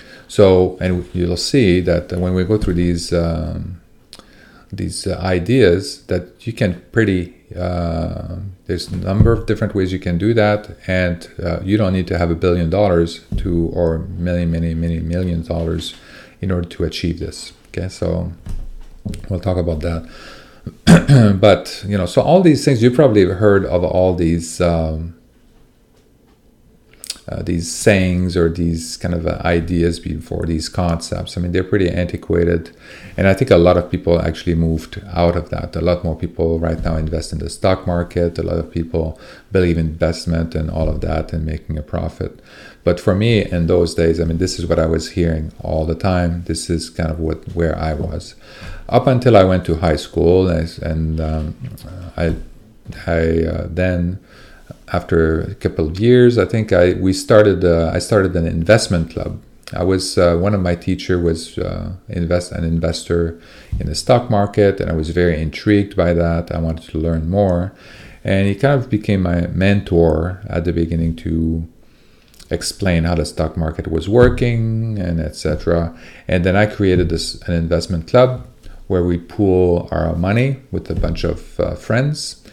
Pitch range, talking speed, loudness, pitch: 85-95 Hz, 180 wpm, -17 LUFS, 90 Hz